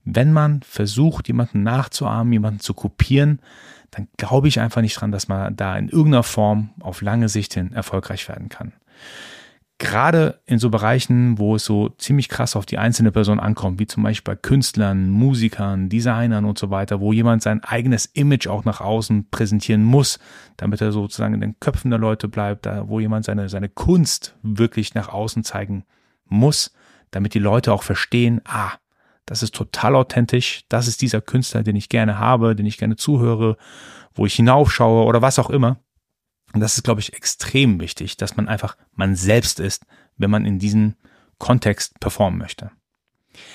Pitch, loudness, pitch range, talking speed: 110 Hz, -19 LUFS, 105-120 Hz, 180 wpm